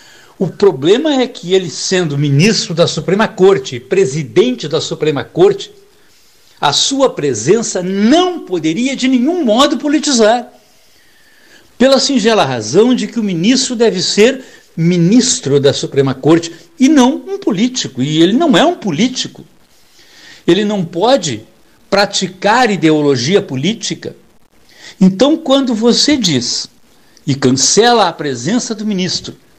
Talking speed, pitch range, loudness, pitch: 125 wpm, 170-260 Hz, -12 LUFS, 210 Hz